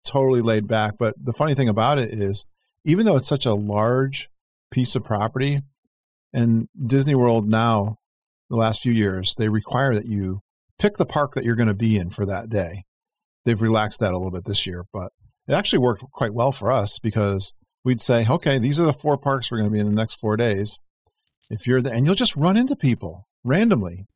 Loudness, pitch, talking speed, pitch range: -21 LUFS, 115 Hz, 215 wpm, 105-135 Hz